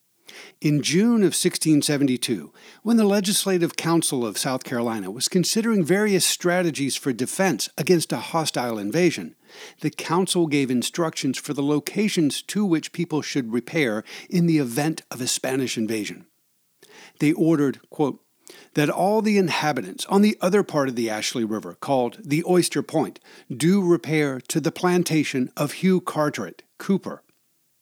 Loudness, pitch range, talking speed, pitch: -22 LUFS, 135-180 Hz, 150 wpm, 155 Hz